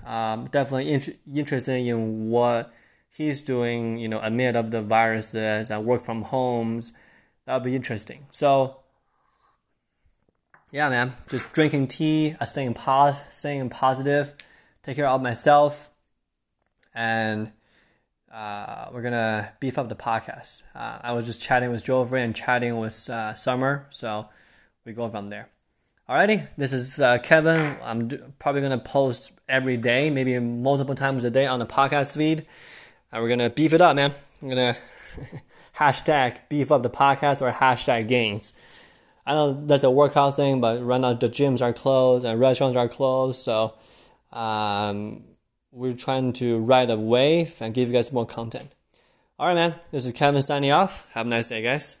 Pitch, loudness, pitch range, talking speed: 125 Hz, -22 LUFS, 115-140 Hz, 170 wpm